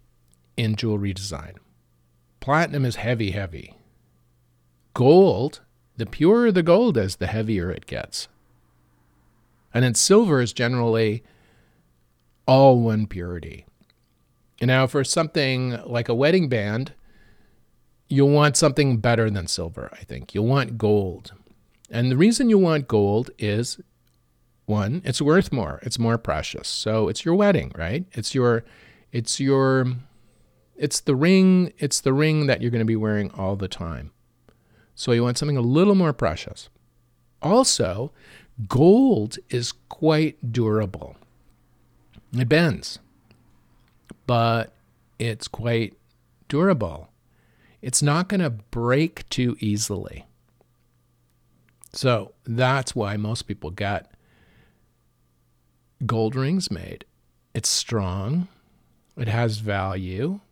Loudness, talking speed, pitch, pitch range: -22 LUFS, 120 wpm, 115 Hz, 100-135 Hz